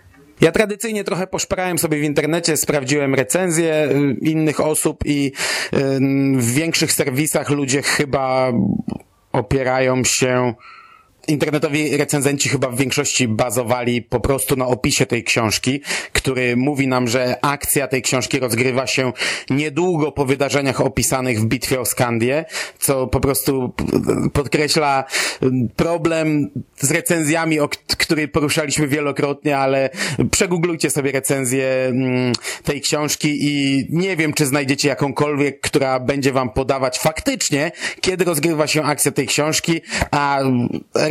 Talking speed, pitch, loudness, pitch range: 120 wpm, 145 Hz, -18 LUFS, 130-155 Hz